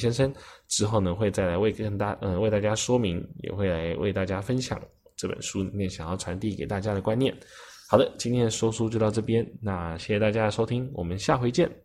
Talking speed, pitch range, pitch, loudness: 330 characters per minute, 95-115 Hz, 105 Hz, -27 LUFS